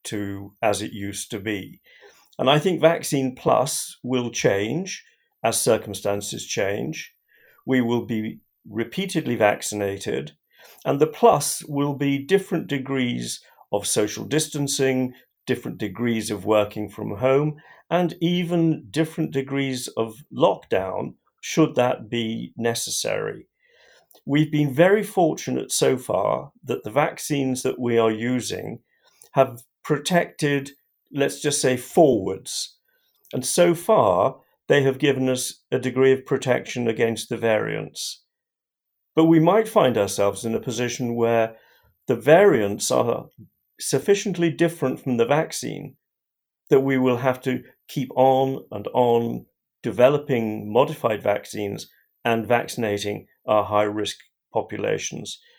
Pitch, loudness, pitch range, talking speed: 130 Hz, -23 LUFS, 115-155 Hz, 125 wpm